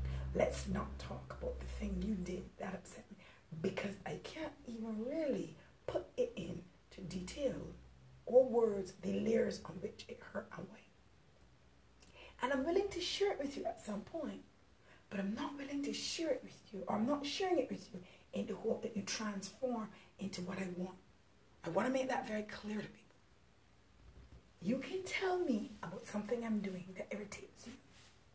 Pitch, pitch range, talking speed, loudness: 210 Hz, 185-265 Hz, 185 wpm, -40 LUFS